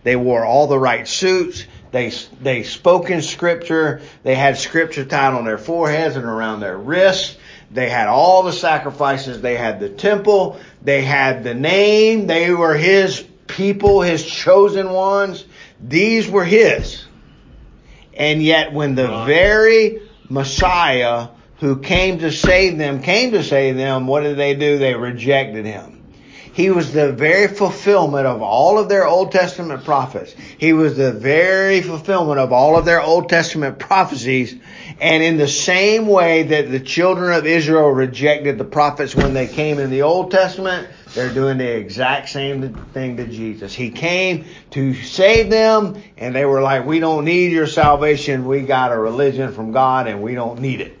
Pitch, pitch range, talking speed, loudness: 150 Hz, 135-185 Hz, 170 wpm, -15 LUFS